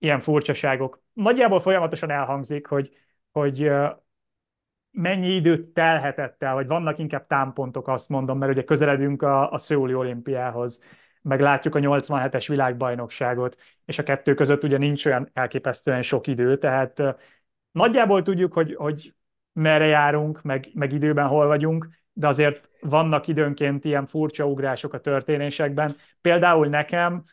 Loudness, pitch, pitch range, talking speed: -22 LUFS, 145 Hz, 135-155 Hz, 135 wpm